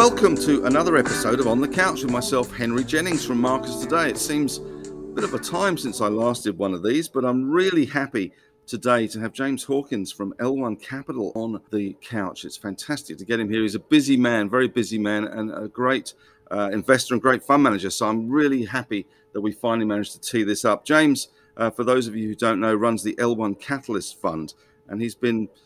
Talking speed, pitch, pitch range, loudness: 220 wpm, 120 Hz, 105-130 Hz, -23 LUFS